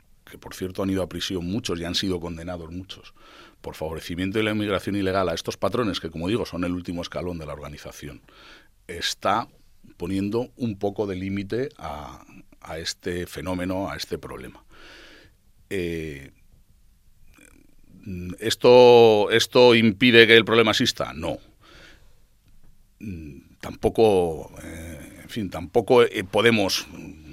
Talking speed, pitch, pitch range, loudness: 135 wpm, 95 Hz, 85-105 Hz, -21 LUFS